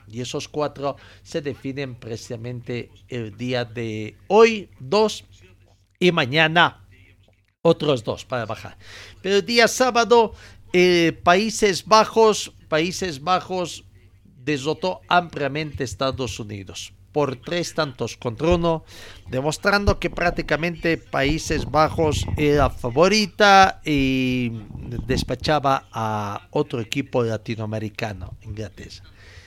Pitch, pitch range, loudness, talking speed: 135 Hz, 110-170 Hz, -21 LUFS, 100 wpm